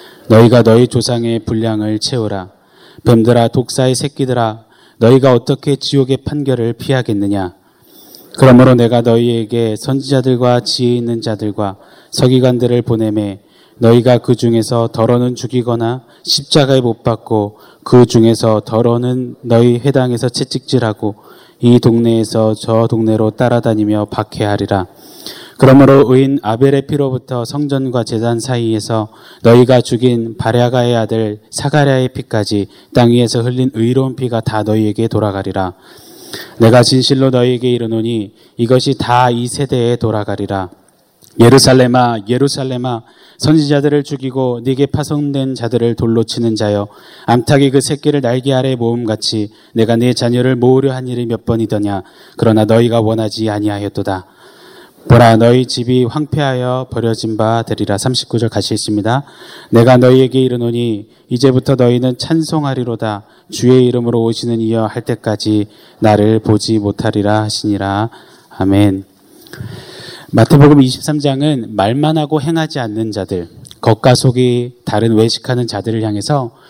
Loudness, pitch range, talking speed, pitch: -12 LUFS, 110-130 Hz, 315 characters per minute, 120 Hz